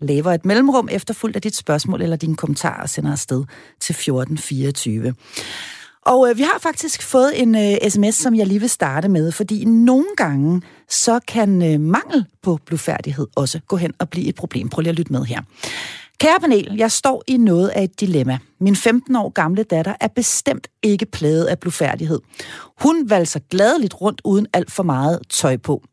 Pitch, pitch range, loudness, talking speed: 185 Hz, 155-225 Hz, -18 LUFS, 190 wpm